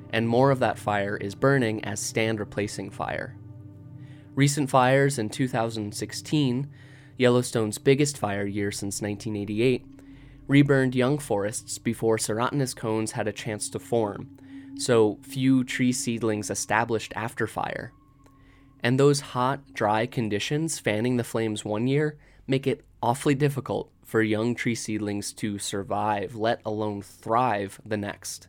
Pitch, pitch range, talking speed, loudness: 115 Hz, 105-135 Hz, 135 wpm, -26 LUFS